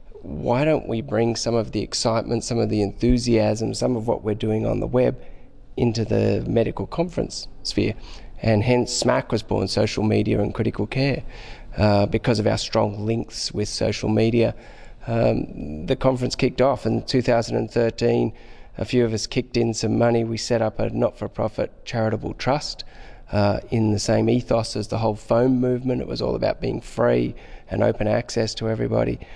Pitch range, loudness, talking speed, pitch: 105-120 Hz, -22 LUFS, 190 wpm, 115 Hz